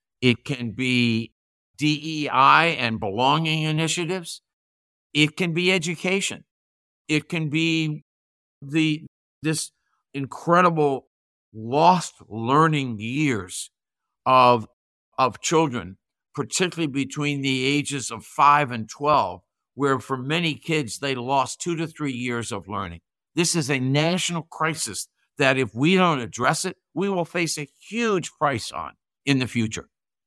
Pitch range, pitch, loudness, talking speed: 120-160 Hz, 145 Hz, -23 LUFS, 125 wpm